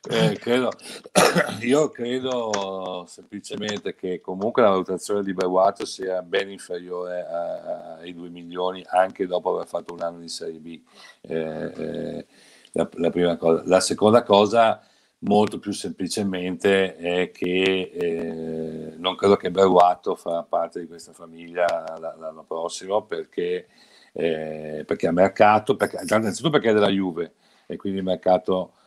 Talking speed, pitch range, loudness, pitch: 140 wpm, 85-100 Hz, -23 LUFS, 90 Hz